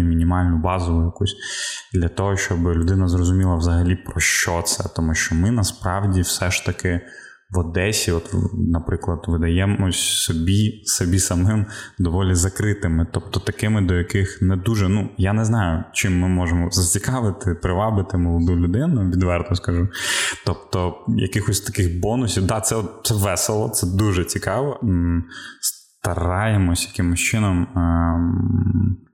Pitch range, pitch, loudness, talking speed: 85-105 Hz, 95 Hz, -20 LUFS, 130 wpm